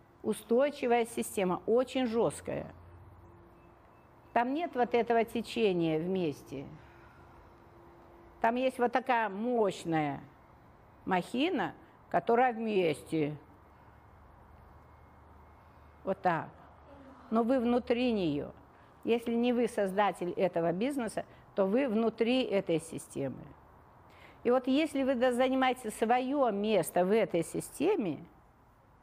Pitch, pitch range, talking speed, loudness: 220 Hz, 170-245 Hz, 95 wpm, -31 LUFS